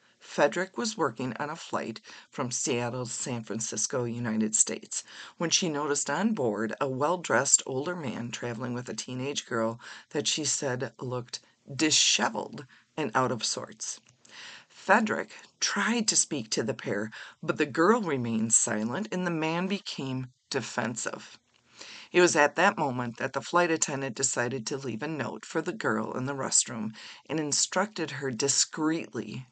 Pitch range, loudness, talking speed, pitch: 120-165 Hz, -28 LUFS, 155 wpm, 140 Hz